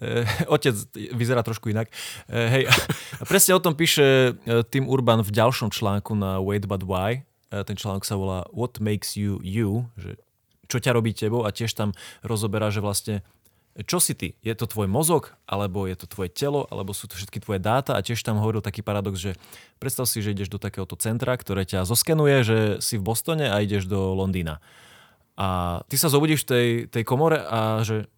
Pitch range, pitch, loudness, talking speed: 100-125 Hz, 110 Hz, -24 LUFS, 200 wpm